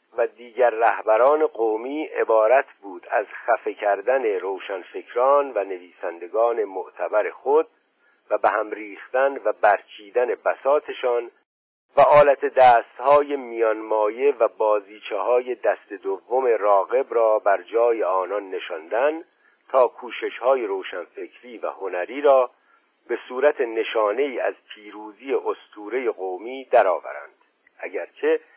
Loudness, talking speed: -22 LUFS, 110 wpm